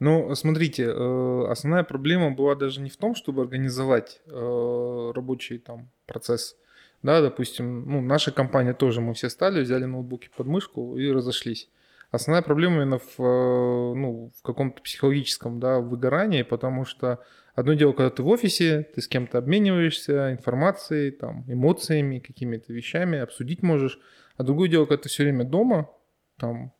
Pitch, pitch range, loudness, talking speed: 130 Hz, 125-150 Hz, -24 LUFS, 150 wpm